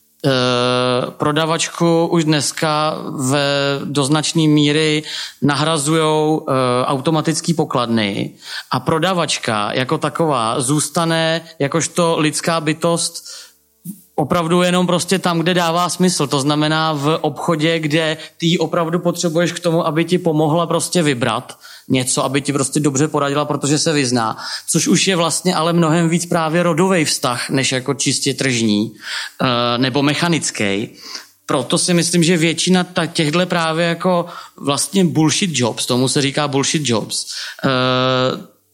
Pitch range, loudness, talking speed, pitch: 140-170 Hz, -16 LUFS, 125 wpm, 155 Hz